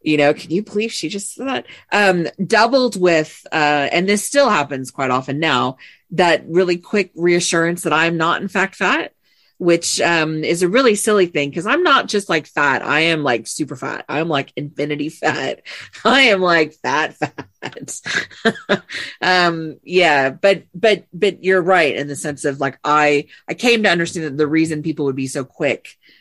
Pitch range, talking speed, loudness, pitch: 150-190 Hz, 190 wpm, -17 LUFS, 170 Hz